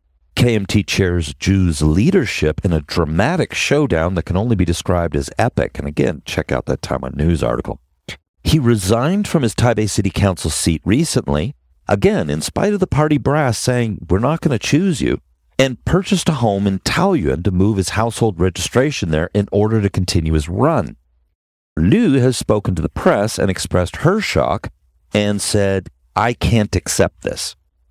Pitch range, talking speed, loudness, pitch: 80-115 Hz, 170 wpm, -17 LUFS, 95 Hz